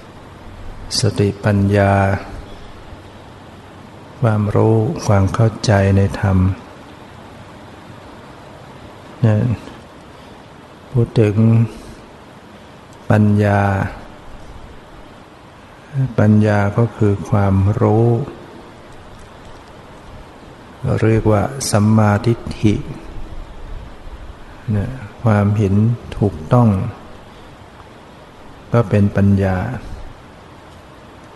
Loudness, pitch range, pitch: -16 LUFS, 100-115 Hz, 105 Hz